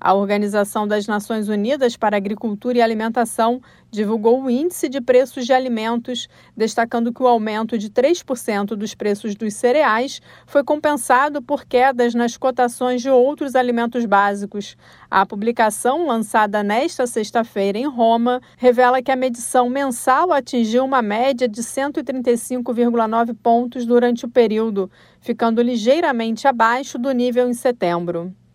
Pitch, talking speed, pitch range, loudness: 240 Hz, 135 wpm, 220-255 Hz, -18 LUFS